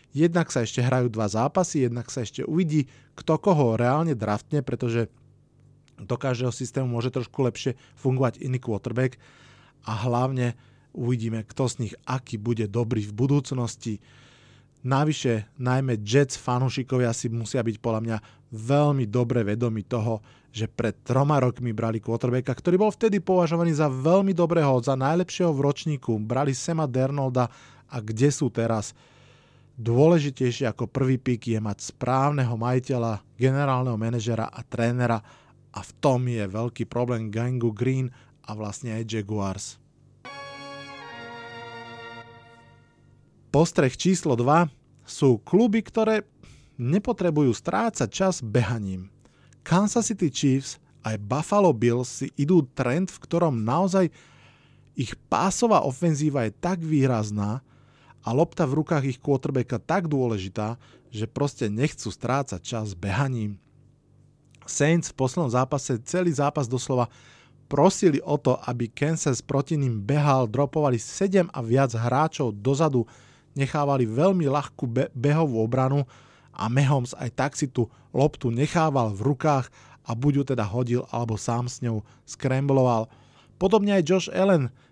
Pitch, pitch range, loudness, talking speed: 130 Hz, 120-145 Hz, -25 LUFS, 135 wpm